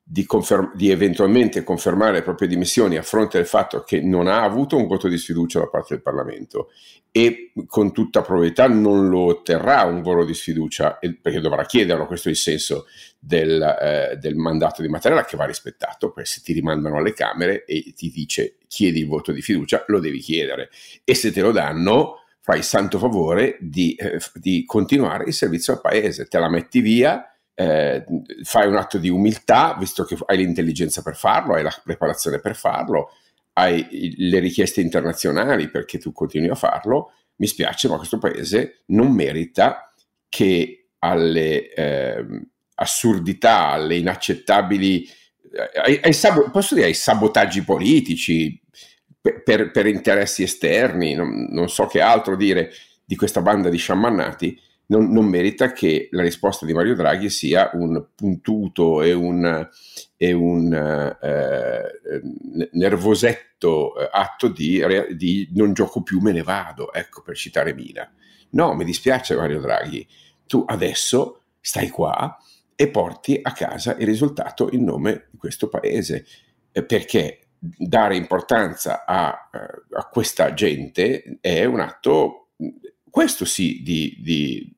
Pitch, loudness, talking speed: 95 Hz, -19 LUFS, 155 wpm